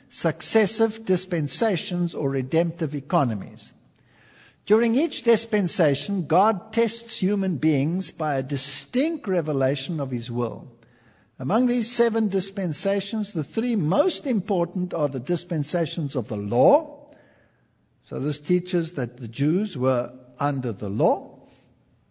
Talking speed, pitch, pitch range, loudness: 115 wpm, 175 Hz, 140-215 Hz, -24 LUFS